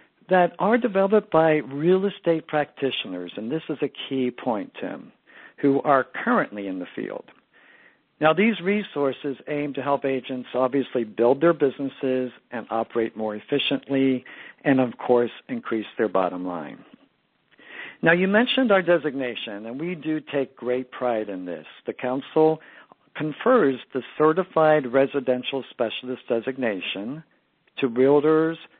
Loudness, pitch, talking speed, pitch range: -23 LUFS, 140 Hz, 135 wpm, 125-160 Hz